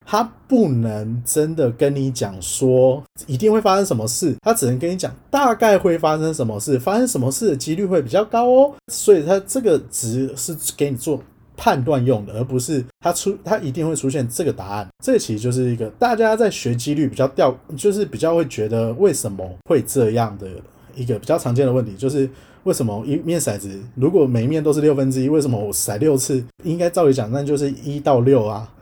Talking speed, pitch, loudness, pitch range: 315 characters per minute, 140 Hz, -19 LUFS, 125-170 Hz